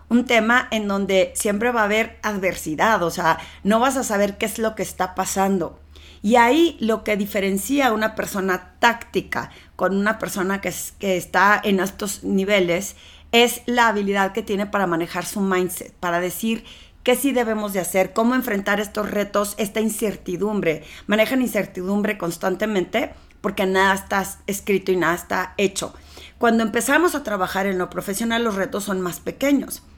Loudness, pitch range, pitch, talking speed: -21 LUFS, 185-225 Hz, 205 Hz, 170 wpm